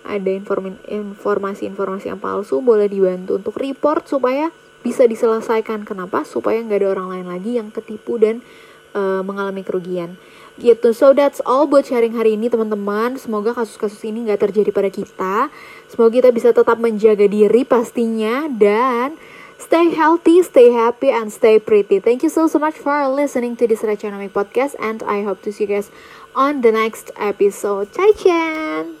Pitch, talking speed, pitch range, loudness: 225 Hz, 165 wpm, 205-265 Hz, -17 LUFS